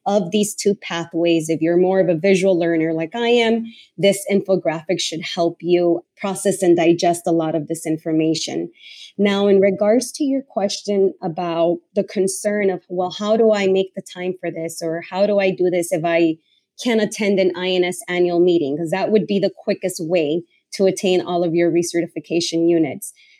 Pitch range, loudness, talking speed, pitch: 170-200 Hz, -19 LUFS, 190 wpm, 180 Hz